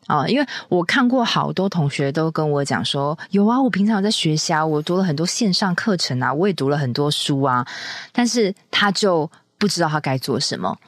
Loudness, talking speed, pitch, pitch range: -19 LUFS, 290 characters per minute, 170 Hz, 145-205 Hz